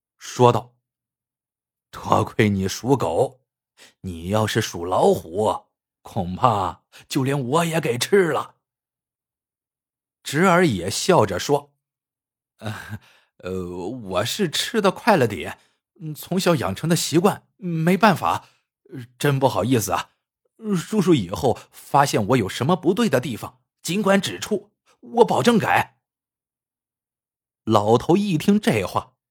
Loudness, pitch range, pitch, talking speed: -21 LUFS, 110-160 Hz, 130 Hz, 170 characters per minute